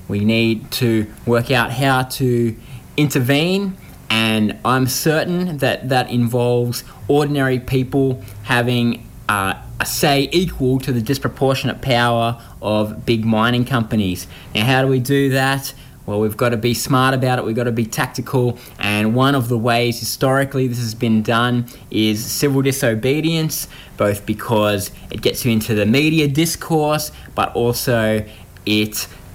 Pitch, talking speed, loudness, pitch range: 120 Hz, 150 wpm, -18 LUFS, 110-135 Hz